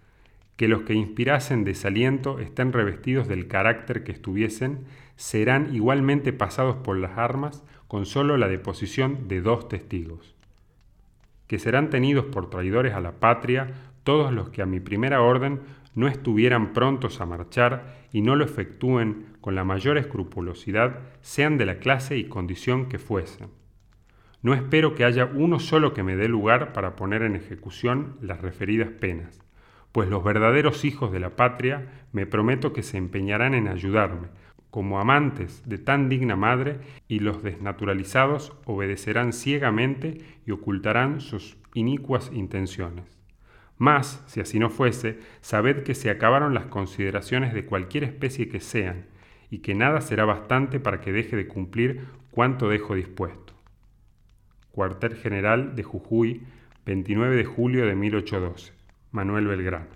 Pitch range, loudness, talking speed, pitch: 100-130 Hz, -24 LUFS, 145 wpm, 115 Hz